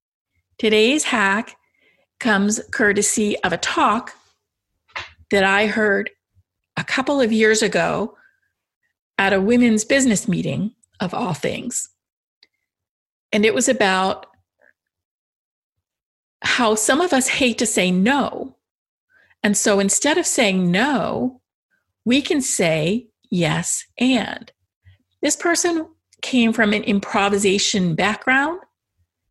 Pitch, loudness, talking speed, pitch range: 215 Hz, -18 LUFS, 110 wpm, 195-255 Hz